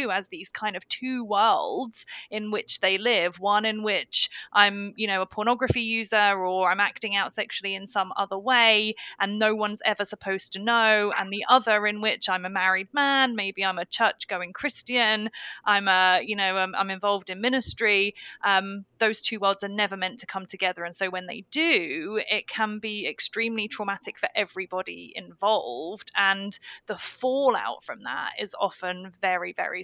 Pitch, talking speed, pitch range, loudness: 205 Hz, 180 wpm, 190-220 Hz, -25 LUFS